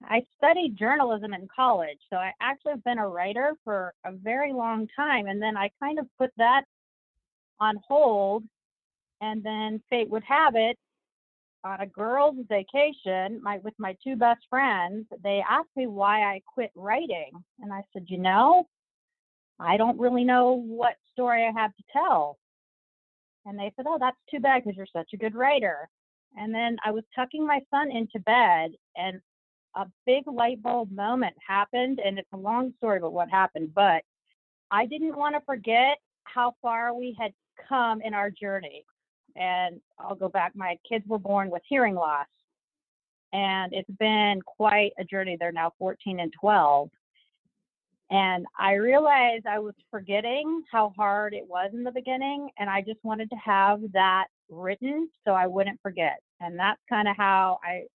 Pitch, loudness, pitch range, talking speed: 215 Hz, -26 LUFS, 195-250 Hz, 175 wpm